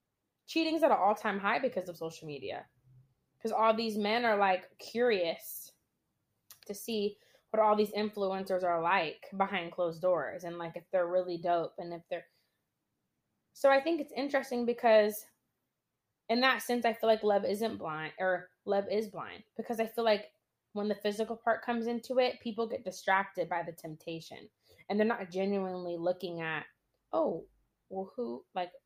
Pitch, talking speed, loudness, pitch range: 200 Hz, 175 wpm, -32 LUFS, 175-225 Hz